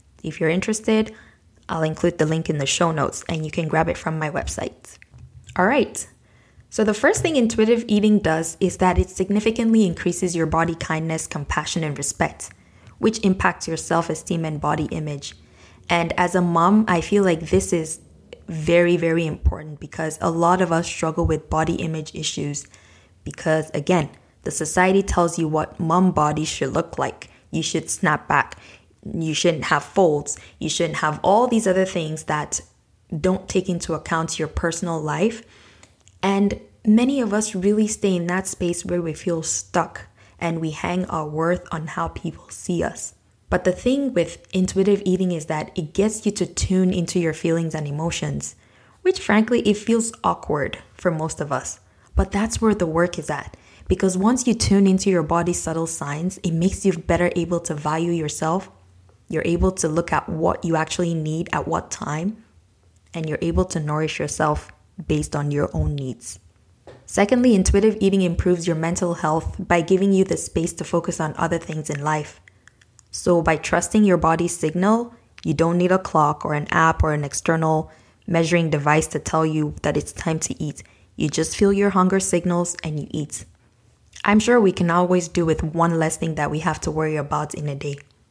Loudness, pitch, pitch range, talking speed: -21 LUFS, 165 Hz, 155-185 Hz, 185 wpm